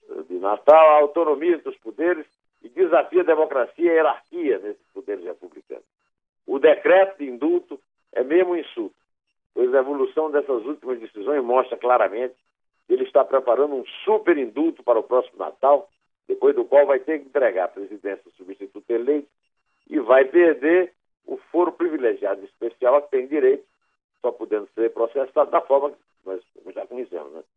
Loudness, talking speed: -21 LUFS, 170 wpm